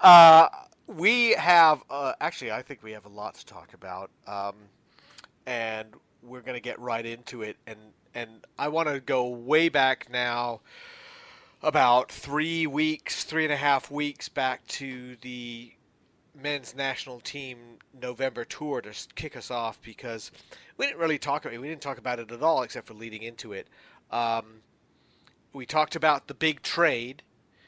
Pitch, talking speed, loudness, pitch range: 125 Hz, 165 wpm, -25 LUFS, 115-150 Hz